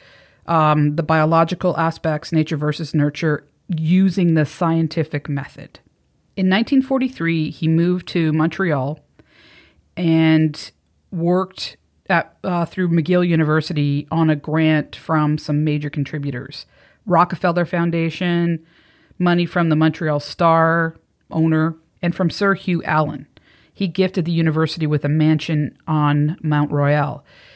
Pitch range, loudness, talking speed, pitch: 150-175 Hz, -19 LUFS, 120 wpm, 160 Hz